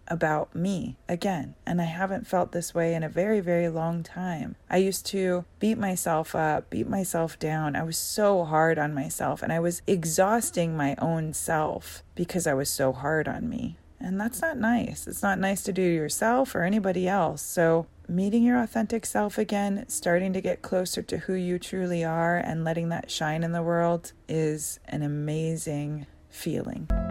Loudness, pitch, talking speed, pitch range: -27 LUFS, 175 Hz, 185 wpm, 160-195 Hz